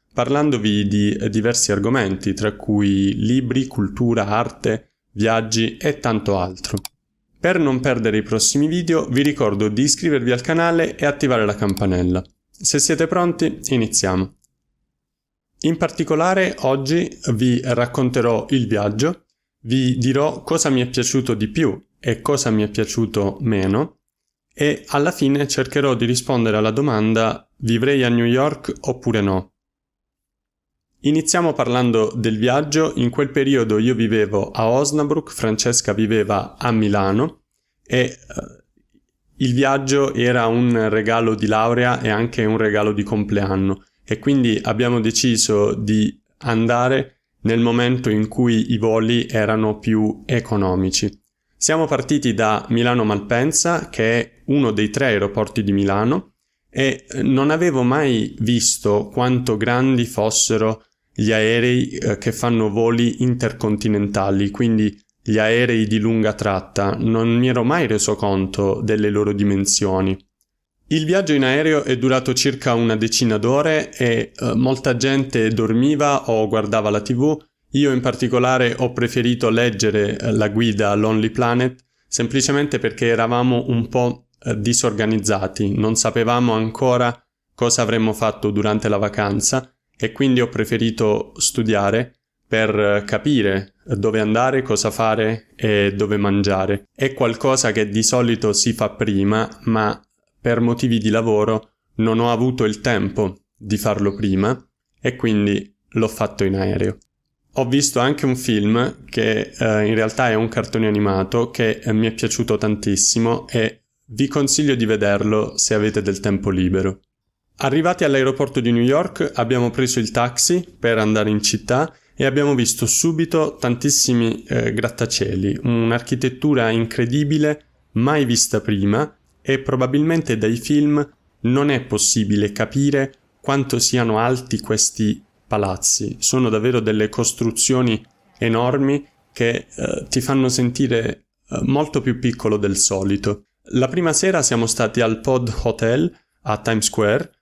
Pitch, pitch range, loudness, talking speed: 115 Hz, 105-130 Hz, -18 LUFS, 135 wpm